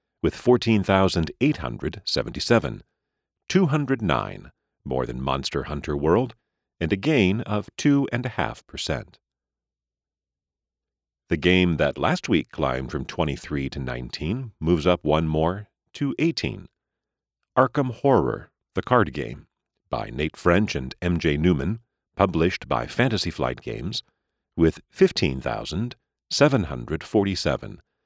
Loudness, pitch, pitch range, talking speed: -24 LUFS, 90 Hz, 70-110 Hz, 100 wpm